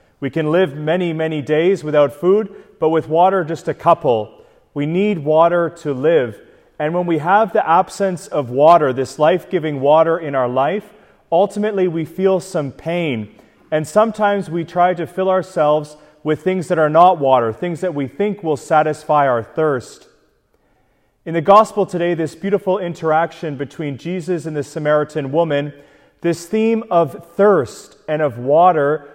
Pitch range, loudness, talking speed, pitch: 150-185 Hz, -17 LUFS, 165 wpm, 165 Hz